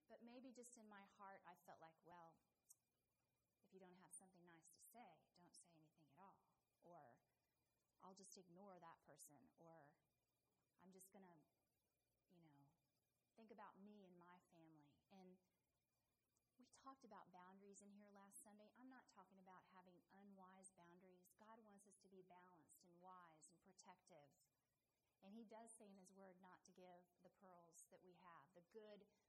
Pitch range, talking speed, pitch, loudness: 170-200 Hz, 175 wpm, 185 Hz, -67 LUFS